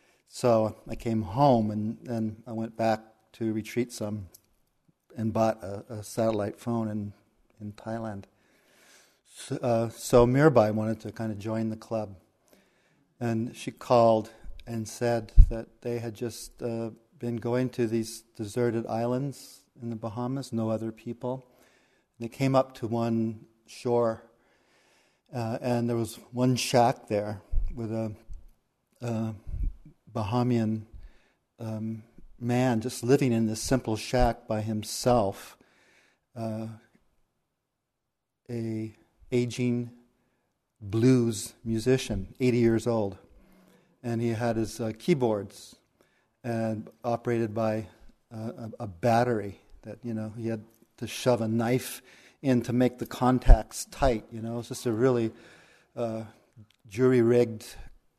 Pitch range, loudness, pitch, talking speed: 110-120 Hz, -29 LUFS, 115 Hz, 130 wpm